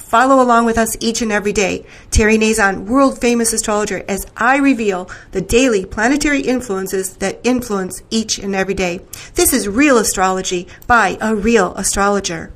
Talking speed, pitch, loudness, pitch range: 165 wpm, 220 Hz, -15 LUFS, 195-240 Hz